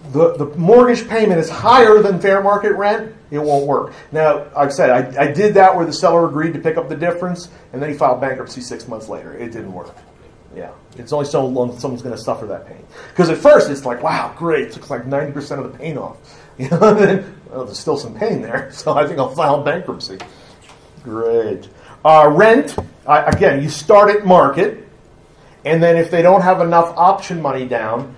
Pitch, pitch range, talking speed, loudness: 160 Hz, 140-185 Hz, 215 wpm, -14 LUFS